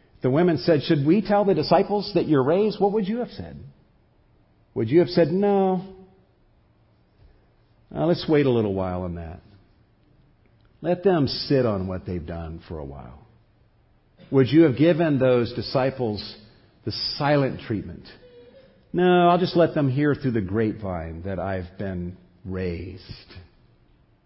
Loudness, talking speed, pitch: -22 LUFS, 150 wpm, 120 Hz